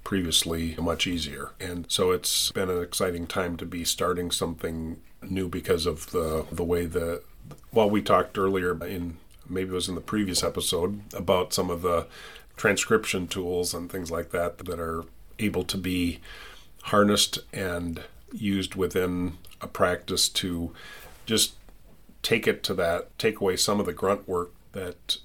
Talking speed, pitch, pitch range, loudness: 165 wpm, 90 Hz, 85-95 Hz, -27 LUFS